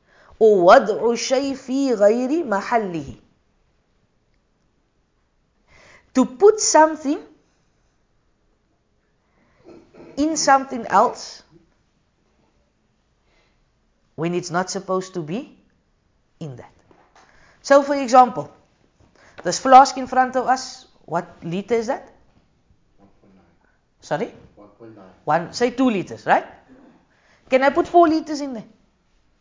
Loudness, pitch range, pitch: -19 LUFS, 175-275 Hz, 245 Hz